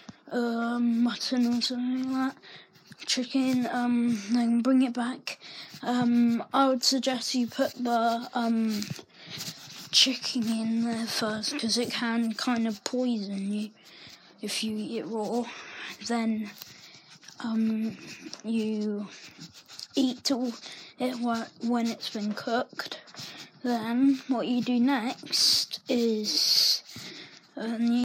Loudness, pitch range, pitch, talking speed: -27 LUFS, 225-250 Hz, 235 Hz, 110 wpm